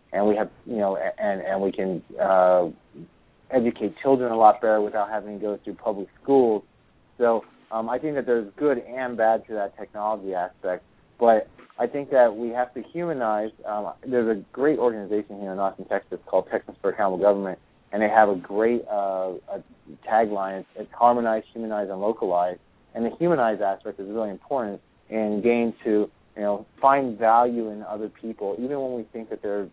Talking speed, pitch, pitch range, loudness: 190 wpm, 110 Hz, 100-120 Hz, -24 LUFS